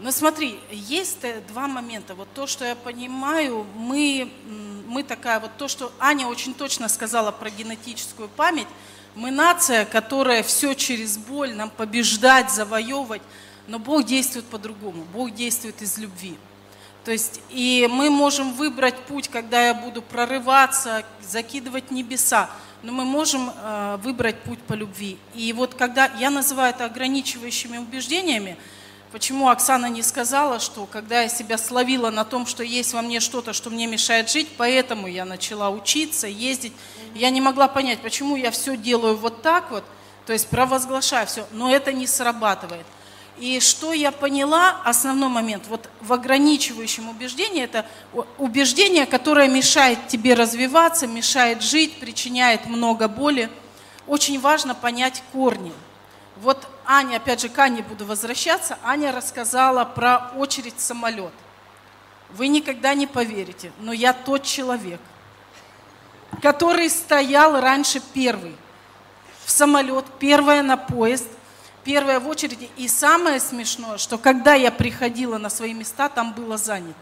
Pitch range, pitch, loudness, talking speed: 225-270 Hz, 245 Hz, -20 LUFS, 145 wpm